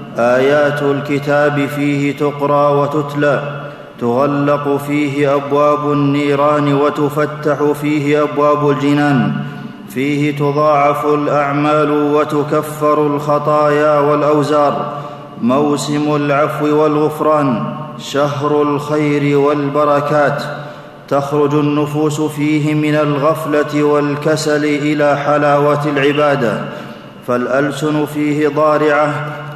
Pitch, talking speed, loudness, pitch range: 145 Hz, 75 wpm, -14 LUFS, 145-150 Hz